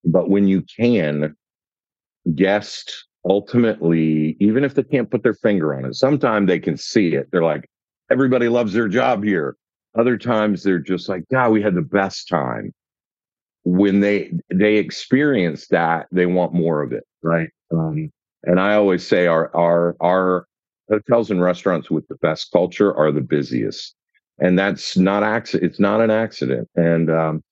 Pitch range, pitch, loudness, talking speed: 85-110 Hz, 95 Hz, -19 LUFS, 165 wpm